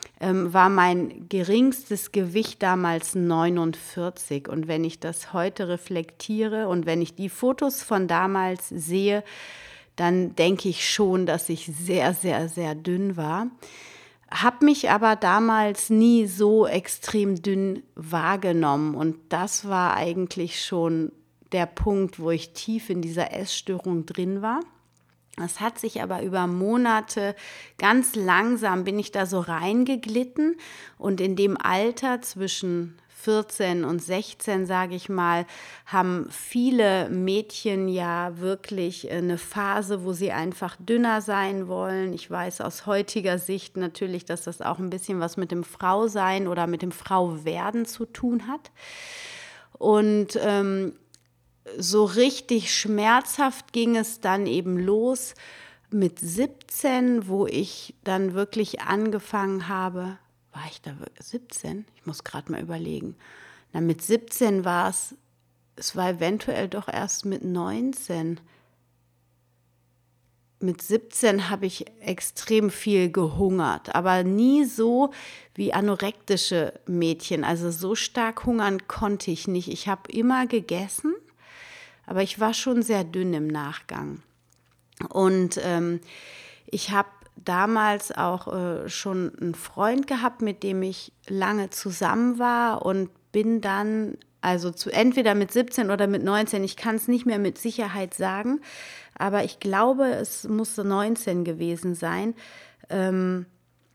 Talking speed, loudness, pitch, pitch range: 135 wpm, -25 LUFS, 195 Hz, 175-220 Hz